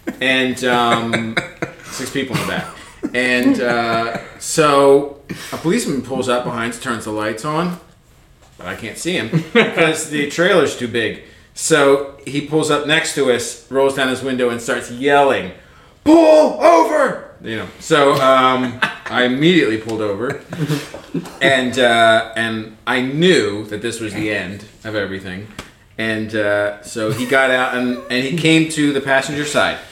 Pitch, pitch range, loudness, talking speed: 130 Hz, 115-145 Hz, -16 LUFS, 160 wpm